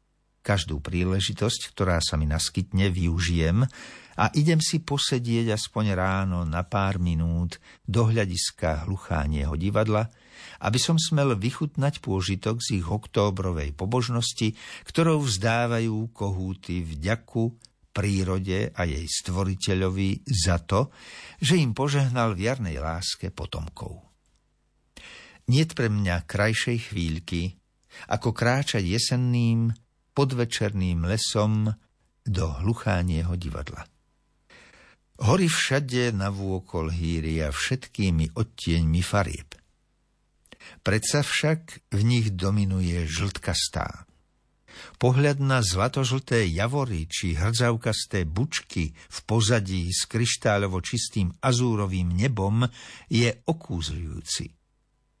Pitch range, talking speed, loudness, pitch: 90-120 Hz, 95 wpm, -26 LUFS, 100 Hz